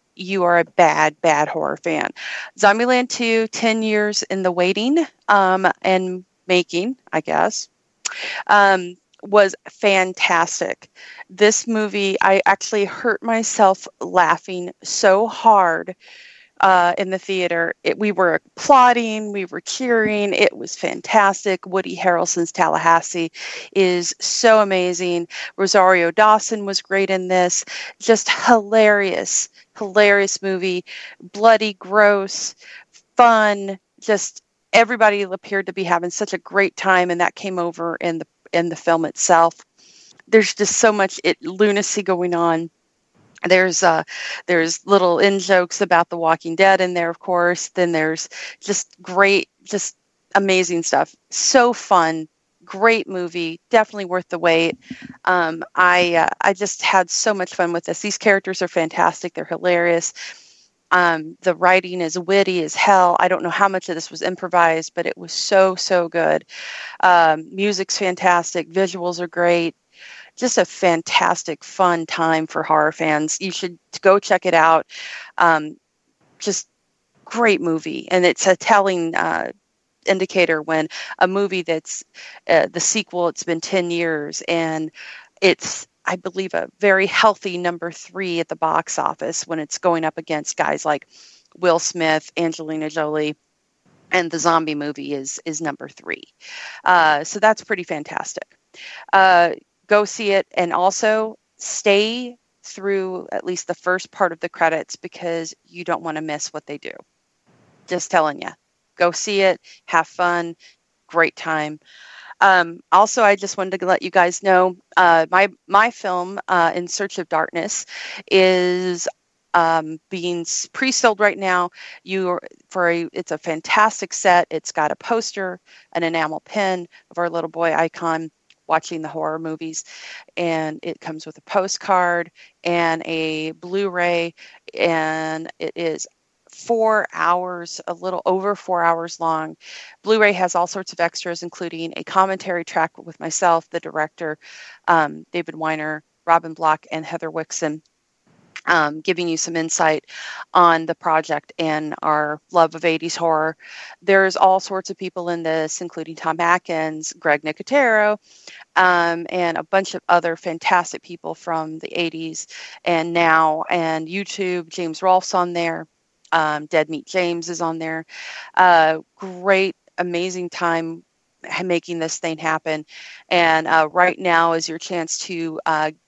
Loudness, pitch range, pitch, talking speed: -18 LUFS, 165-195 Hz, 180 Hz, 150 wpm